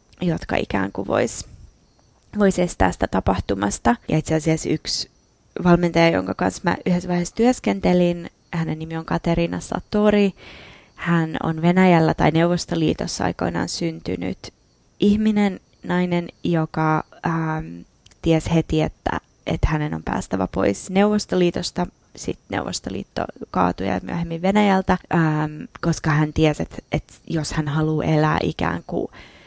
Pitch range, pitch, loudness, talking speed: 155-175 Hz, 160 Hz, -21 LUFS, 125 wpm